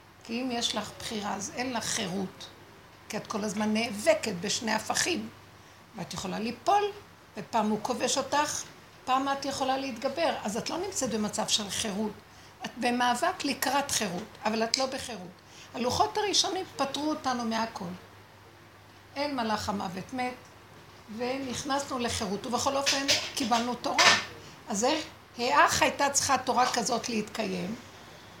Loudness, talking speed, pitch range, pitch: -29 LUFS, 135 wpm, 210-270 Hz, 235 Hz